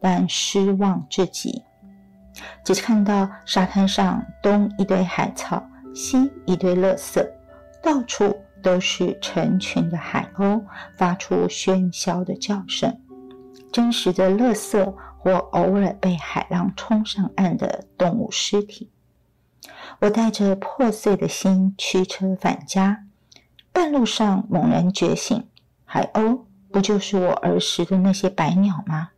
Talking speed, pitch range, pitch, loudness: 180 characters per minute, 185-205 Hz, 195 Hz, -21 LUFS